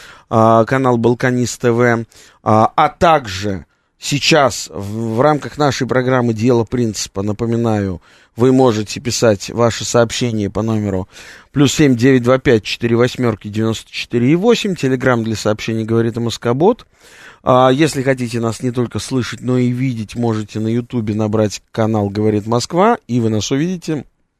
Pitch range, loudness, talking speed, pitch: 110-130 Hz, -15 LUFS, 145 wpm, 120 Hz